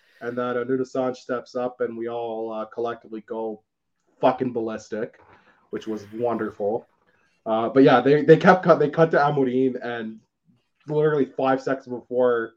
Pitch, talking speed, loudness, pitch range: 125 Hz, 155 wpm, -22 LUFS, 115-130 Hz